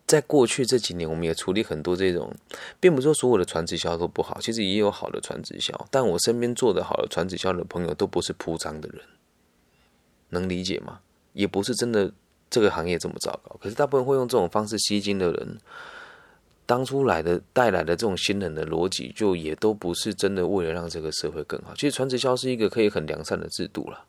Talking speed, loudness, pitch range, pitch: 340 characters per minute, -25 LUFS, 85-125 Hz, 100 Hz